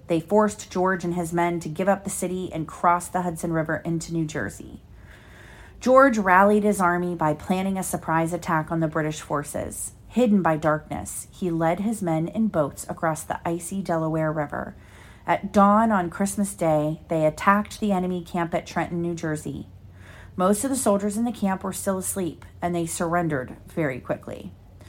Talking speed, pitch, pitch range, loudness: 180 wpm, 175 Hz, 160-195 Hz, -24 LUFS